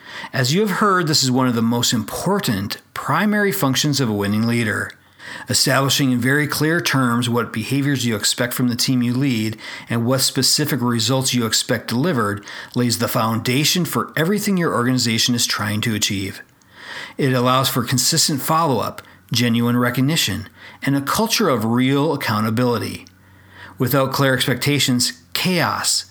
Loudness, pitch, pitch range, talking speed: -18 LUFS, 130 Hz, 115-140 Hz, 155 wpm